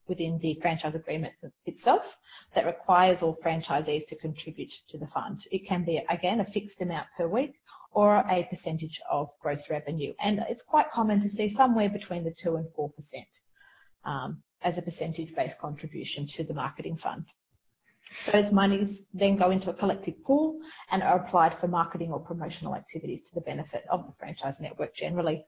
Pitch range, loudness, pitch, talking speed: 160-205 Hz, -29 LUFS, 175 Hz, 175 wpm